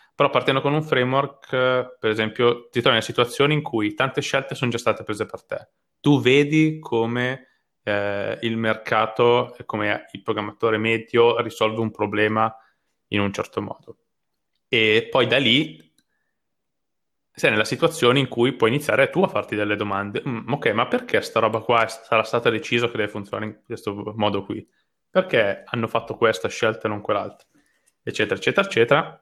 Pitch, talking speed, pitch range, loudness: 115 Hz, 170 wpm, 110-130 Hz, -21 LUFS